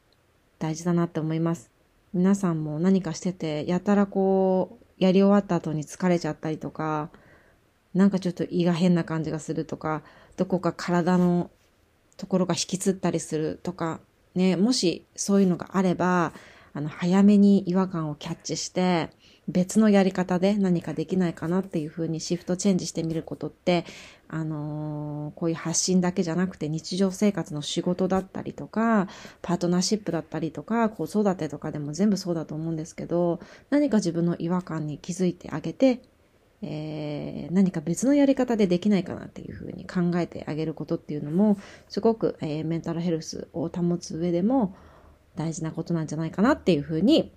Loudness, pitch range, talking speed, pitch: -26 LUFS, 160-190 Hz, 375 characters per minute, 175 Hz